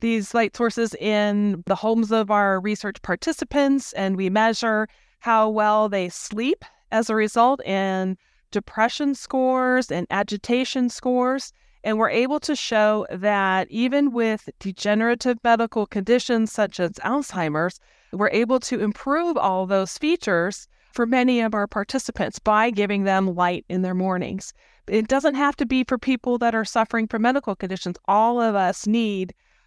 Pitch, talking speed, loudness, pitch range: 220 Hz, 155 wpm, -22 LUFS, 200-250 Hz